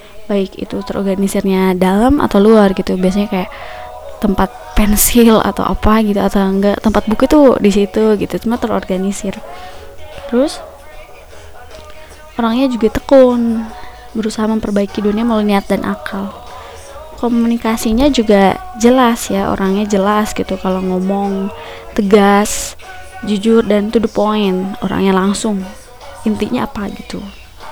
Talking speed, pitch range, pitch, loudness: 120 wpm, 195-230 Hz, 210 Hz, -14 LUFS